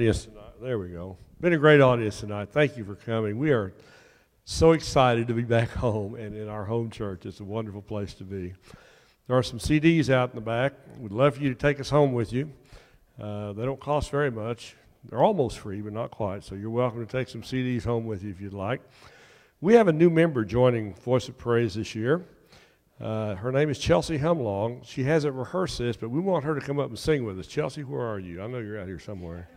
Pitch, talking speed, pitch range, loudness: 115 Hz, 235 wpm, 105-135 Hz, -26 LUFS